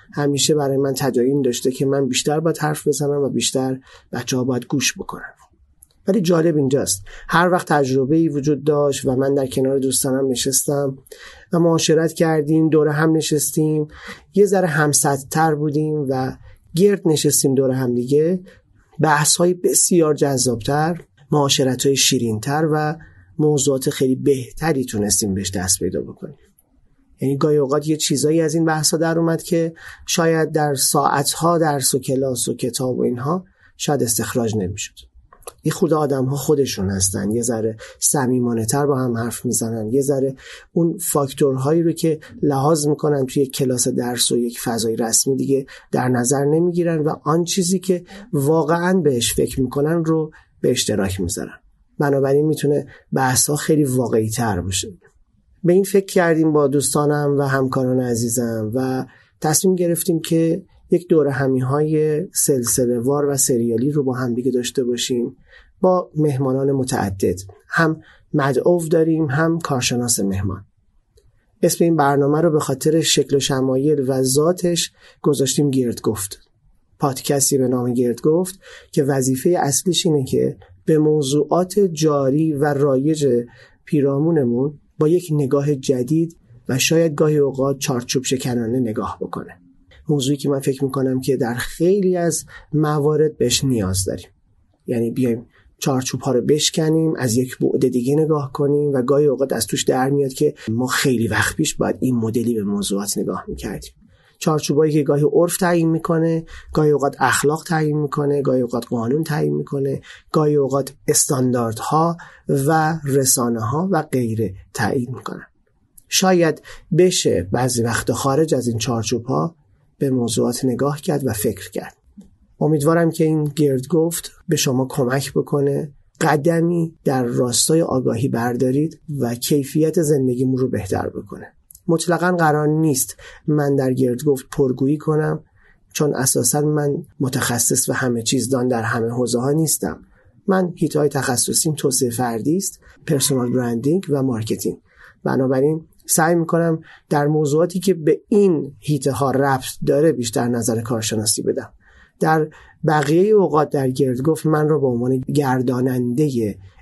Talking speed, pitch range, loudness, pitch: 145 wpm, 125-155 Hz, -19 LUFS, 140 Hz